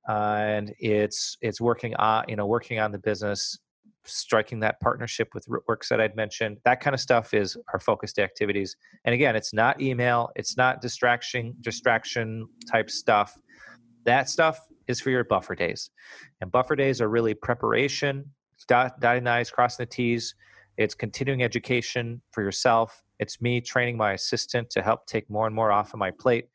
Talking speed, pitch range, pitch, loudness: 180 wpm, 110-125 Hz, 120 Hz, -26 LUFS